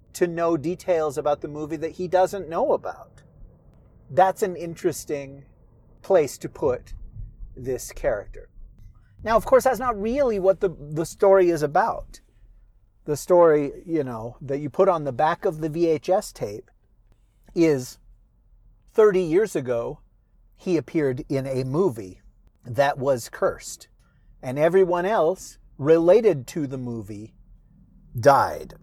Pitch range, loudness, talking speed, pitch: 120-180 Hz, -23 LUFS, 135 wpm, 150 Hz